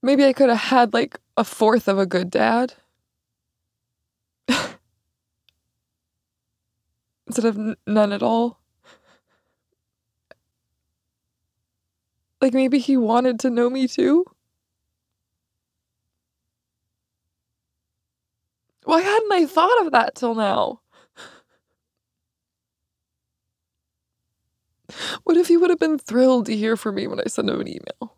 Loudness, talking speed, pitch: -20 LUFS, 110 wpm, 220 Hz